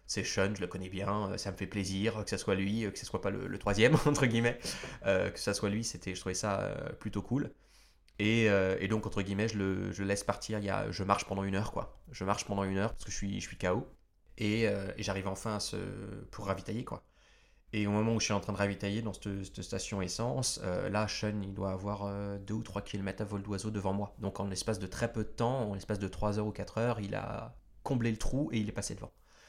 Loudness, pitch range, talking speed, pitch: -34 LUFS, 100-110 Hz, 280 wpm, 100 Hz